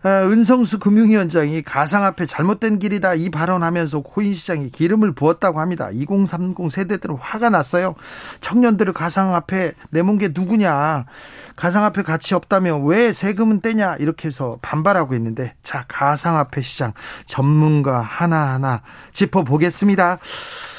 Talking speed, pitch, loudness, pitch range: 320 characters per minute, 175 Hz, -18 LUFS, 150-200 Hz